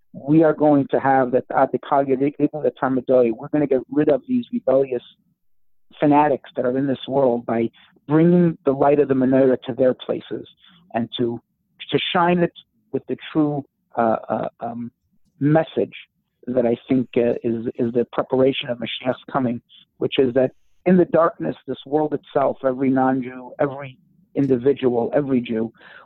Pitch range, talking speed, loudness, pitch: 125-145 Hz, 170 wpm, -20 LUFS, 130 Hz